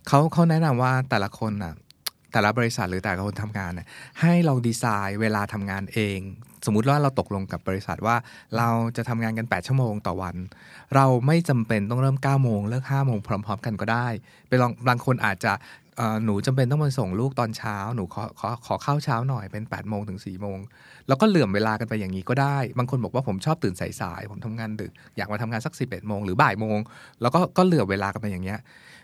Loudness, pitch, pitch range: -25 LUFS, 110 Hz, 100-130 Hz